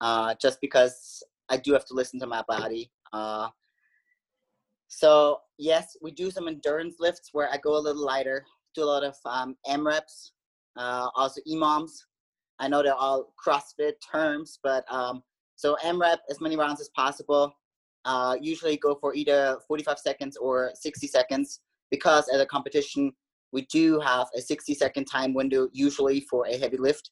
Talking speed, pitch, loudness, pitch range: 170 wpm, 145 Hz, -27 LUFS, 130-155 Hz